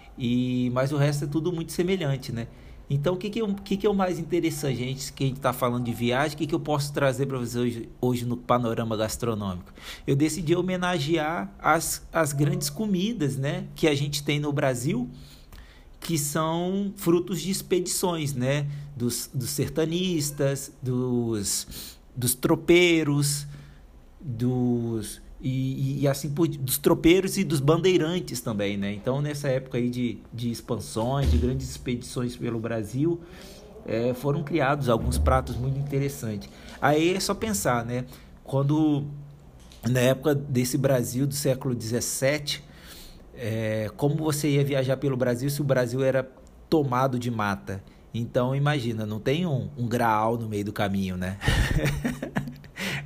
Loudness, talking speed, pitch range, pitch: -26 LUFS, 155 wpm, 120-155 Hz, 135 Hz